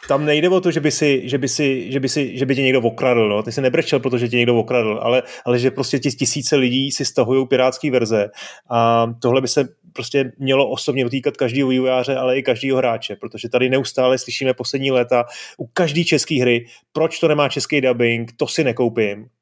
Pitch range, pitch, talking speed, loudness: 120-140 Hz, 130 Hz, 185 wpm, -18 LUFS